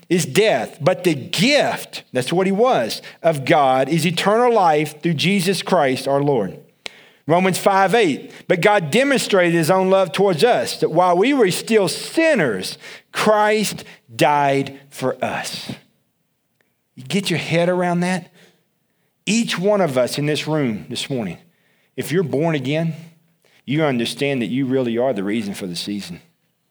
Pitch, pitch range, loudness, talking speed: 170 Hz, 140-195 Hz, -18 LUFS, 155 wpm